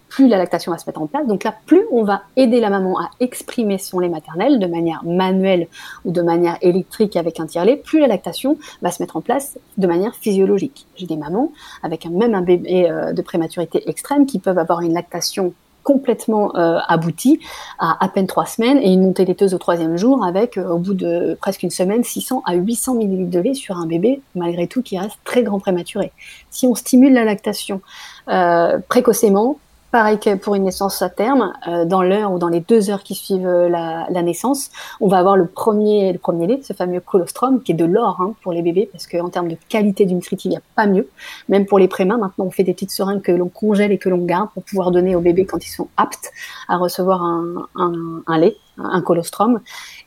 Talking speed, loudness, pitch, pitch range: 225 wpm, -17 LUFS, 190 Hz, 175-220 Hz